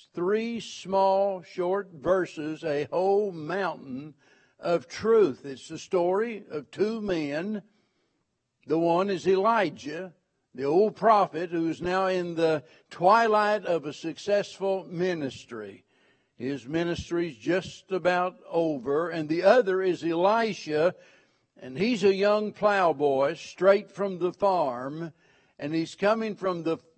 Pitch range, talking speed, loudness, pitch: 160-195 Hz, 125 wpm, -26 LUFS, 180 Hz